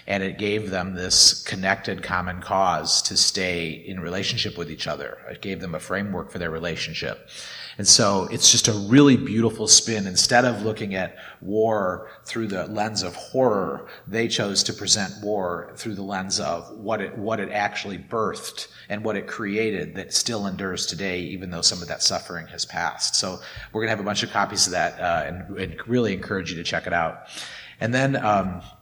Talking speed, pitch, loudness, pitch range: 200 wpm, 100 Hz, -22 LUFS, 95-110 Hz